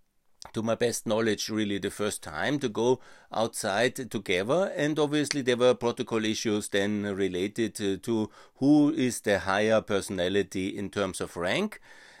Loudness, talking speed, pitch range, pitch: -28 LUFS, 150 wpm, 100-125 Hz, 110 Hz